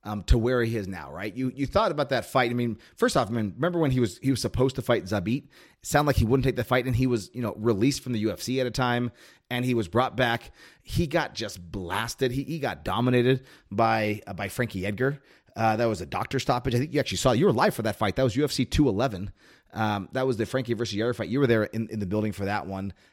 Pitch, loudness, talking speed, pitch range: 120 Hz, -26 LUFS, 270 wpm, 105-130 Hz